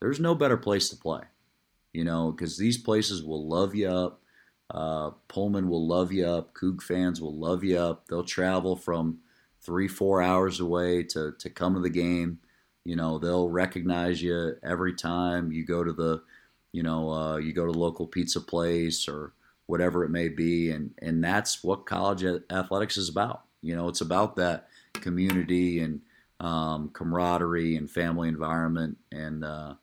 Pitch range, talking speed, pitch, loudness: 80-90 Hz, 175 wpm, 85 Hz, -29 LUFS